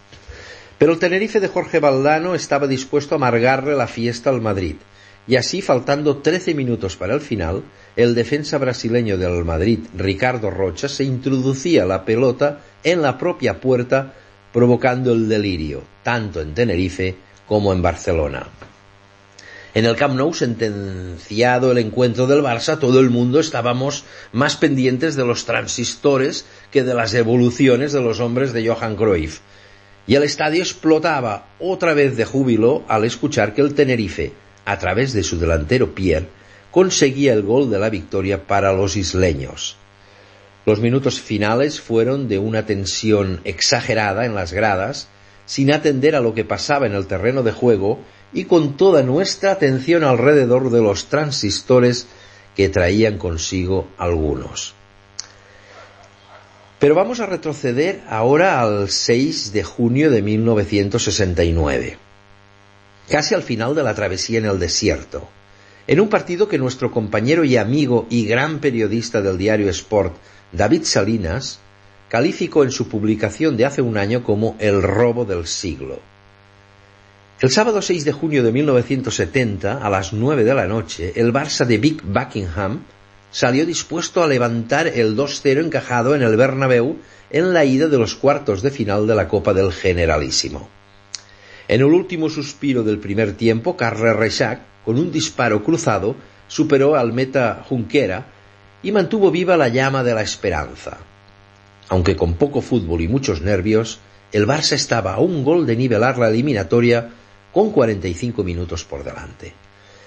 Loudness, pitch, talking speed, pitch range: -18 LUFS, 115 Hz, 150 wpm, 100-135 Hz